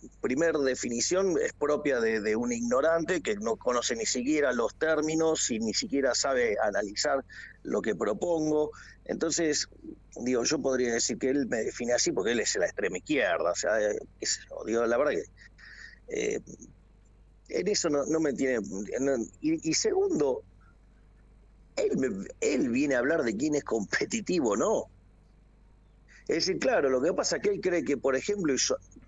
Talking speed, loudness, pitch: 170 wpm, -29 LUFS, 175 Hz